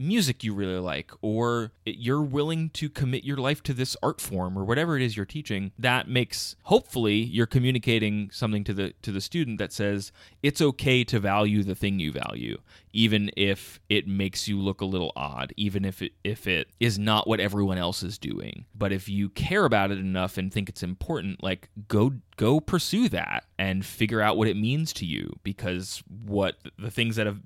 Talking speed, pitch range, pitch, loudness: 205 wpm, 95-120 Hz, 105 Hz, -27 LUFS